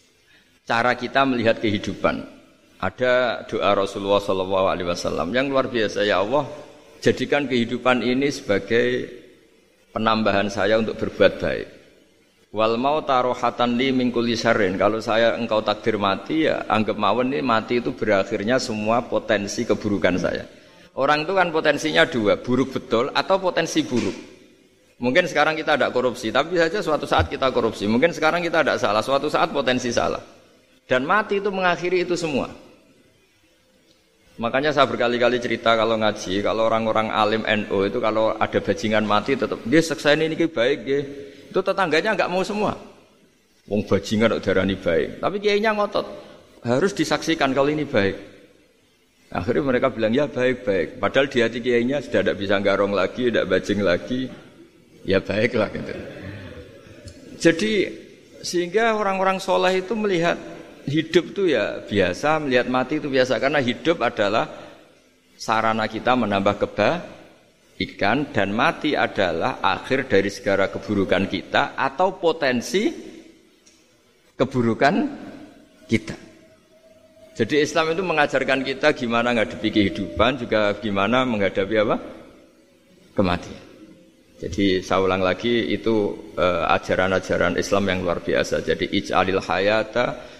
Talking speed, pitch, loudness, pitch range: 130 wpm, 125 Hz, -21 LUFS, 110-160 Hz